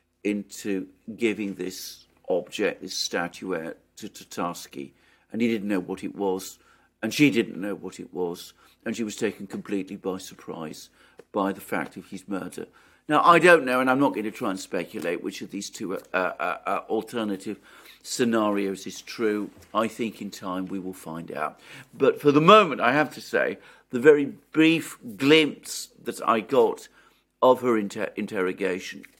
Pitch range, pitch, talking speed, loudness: 95-125 Hz, 105 Hz, 175 wpm, -25 LUFS